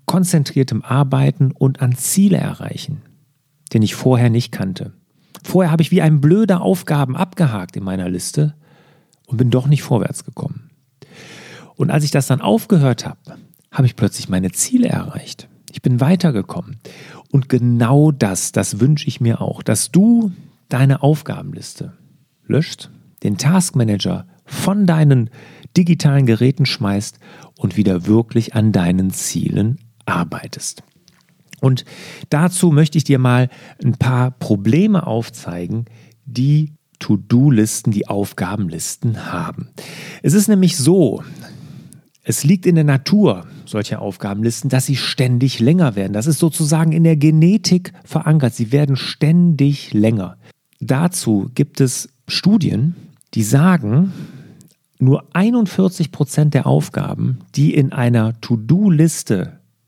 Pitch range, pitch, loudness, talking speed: 120-165 Hz, 145 Hz, -16 LUFS, 130 wpm